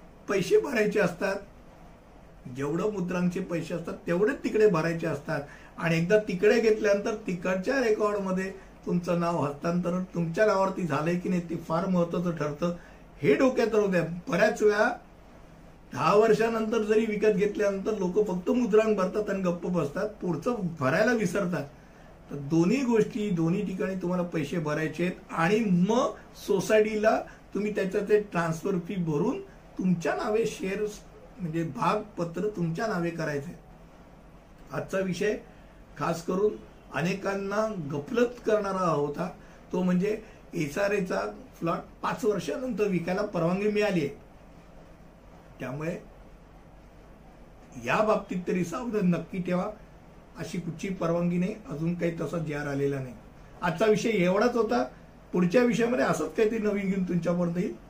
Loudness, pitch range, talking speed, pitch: -28 LUFS, 170-215 Hz, 130 wpm, 190 Hz